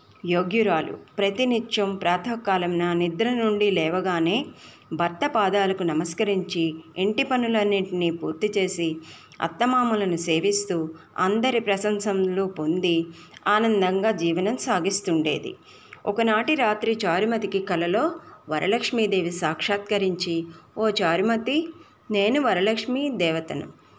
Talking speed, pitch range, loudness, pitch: 85 wpm, 170-220 Hz, -24 LUFS, 195 Hz